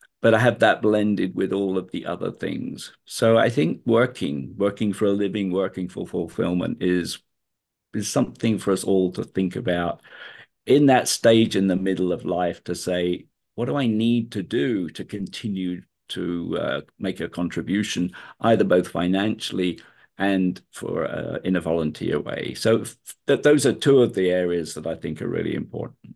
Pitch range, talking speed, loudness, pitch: 90-105 Hz, 180 wpm, -23 LUFS, 95 Hz